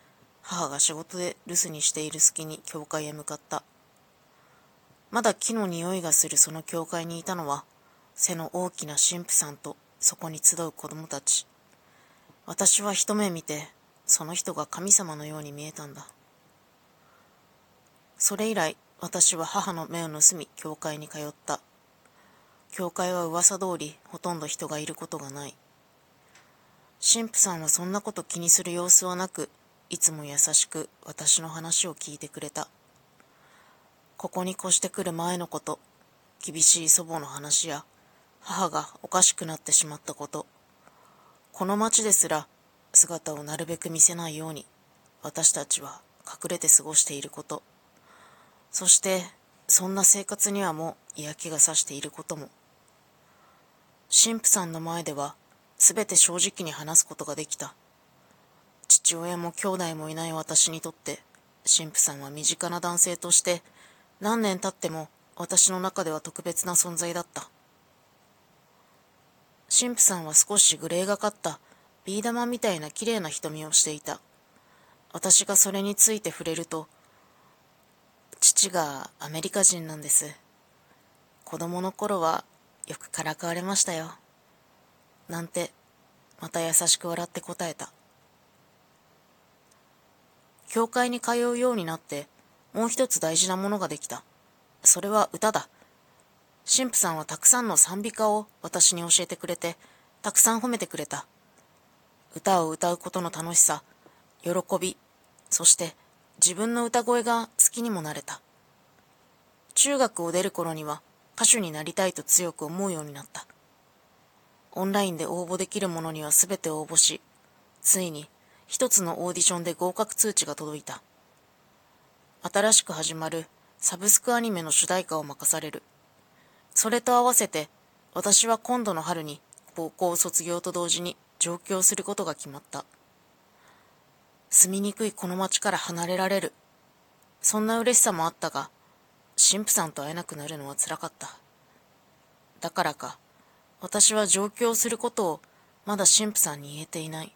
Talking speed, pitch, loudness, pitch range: 275 characters per minute, 175 Hz, -23 LUFS, 155-195 Hz